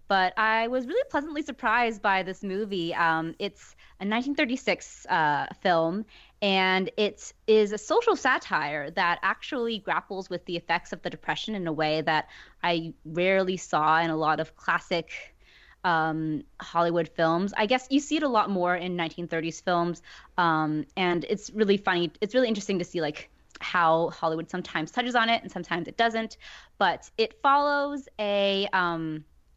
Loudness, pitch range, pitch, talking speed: -27 LUFS, 165-220 Hz, 190 Hz, 165 wpm